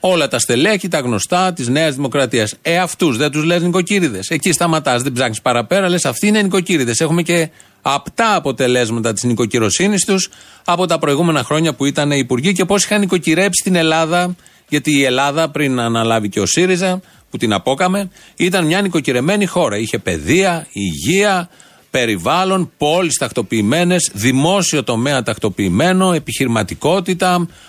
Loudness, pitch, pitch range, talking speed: -15 LUFS, 160 Hz, 125-185 Hz, 150 wpm